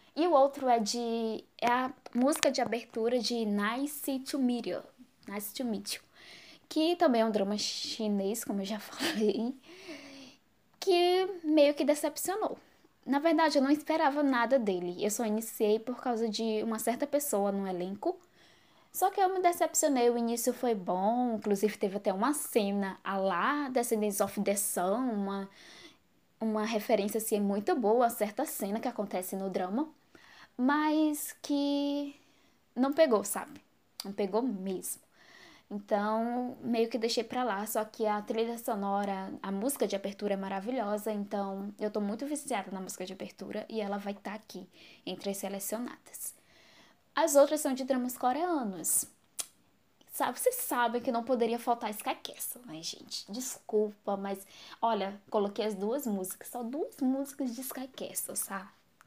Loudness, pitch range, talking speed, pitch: -32 LUFS, 205-275 Hz, 160 wpm, 230 Hz